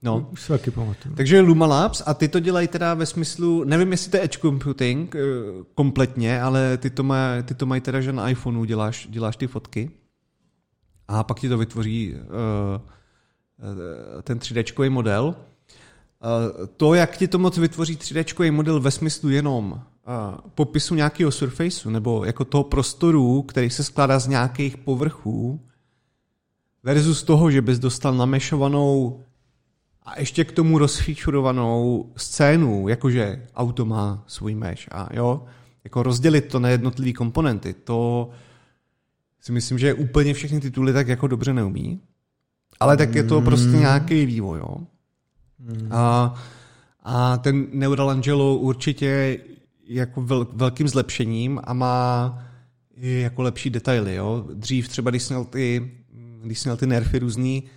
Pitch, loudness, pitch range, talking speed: 130 Hz, -21 LUFS, 120-145 Hz, 140 wpm